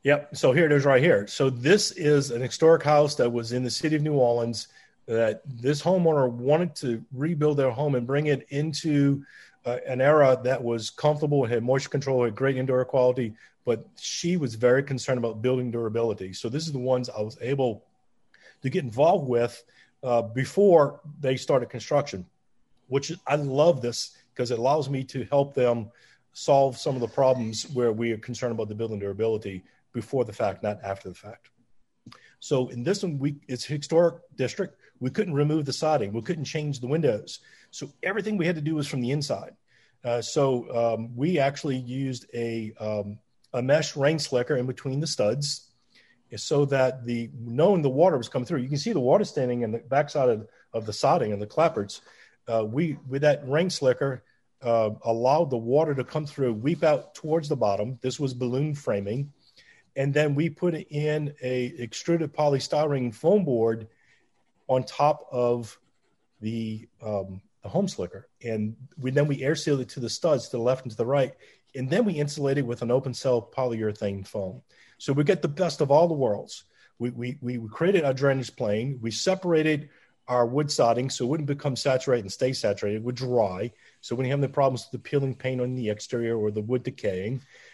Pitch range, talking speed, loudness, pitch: 120-145 Hz, 200 wpm, -26 LUFS, 130 Hz